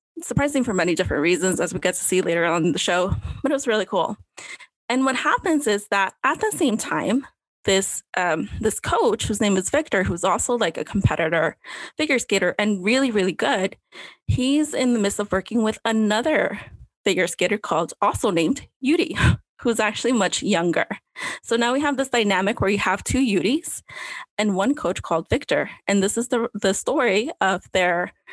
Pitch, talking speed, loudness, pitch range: 220 Hz, 190 wpm, -22 LUFS, 195-270 Hz